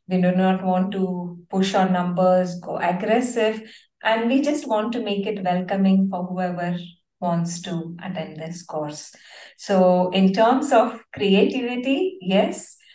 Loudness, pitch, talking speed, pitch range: -22 LUFS, 190 Hz, 145 wpm, 180-220 Hz